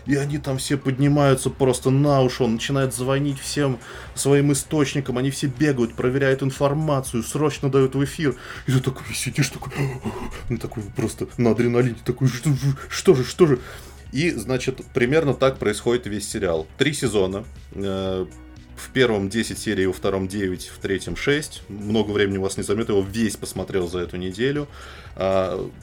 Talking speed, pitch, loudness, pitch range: 165 wpm, 130 Hz, -22 LUFS, 105-140 Hz